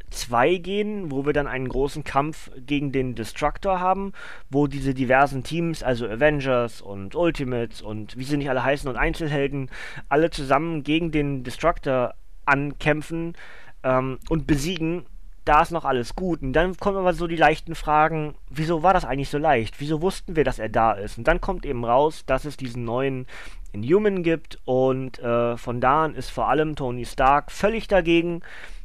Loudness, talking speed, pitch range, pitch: -23 LUFS, 180 wpm, 130-165 Hz, 145 Hz